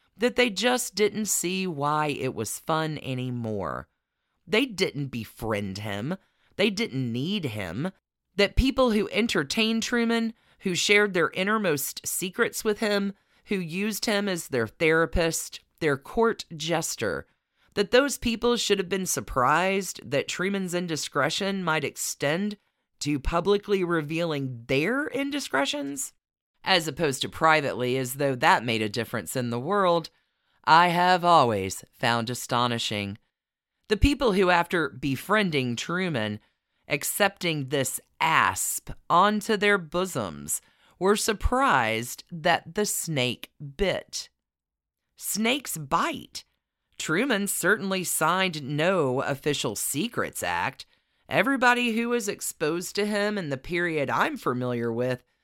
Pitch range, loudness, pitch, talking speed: 135-205 Hz, -26 LUFS, 170 Hz, 120 wpm